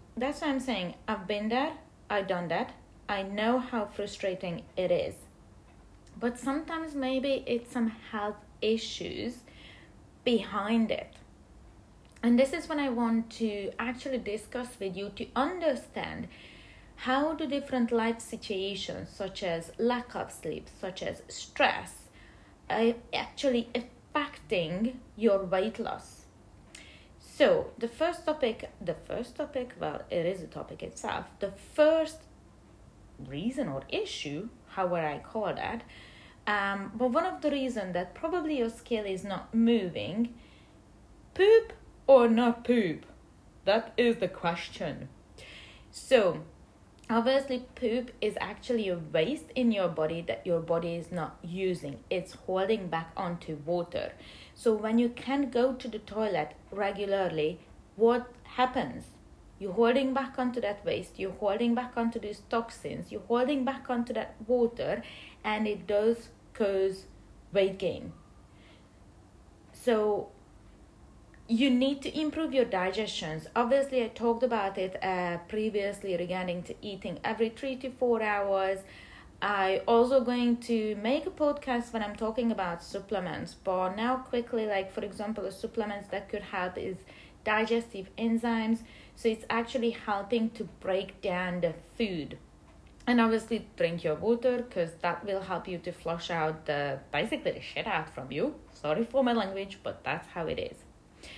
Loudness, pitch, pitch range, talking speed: -31 LUFS, 220 Hz, 190-245 Hz, 145 wpm